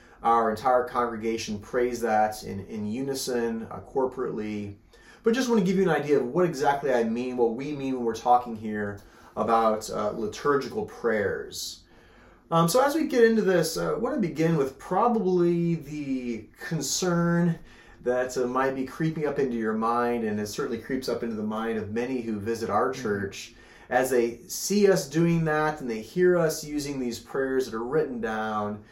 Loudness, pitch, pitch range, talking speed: -26 LUFS, 125 Hz, 115-160 Hz, 185 wpm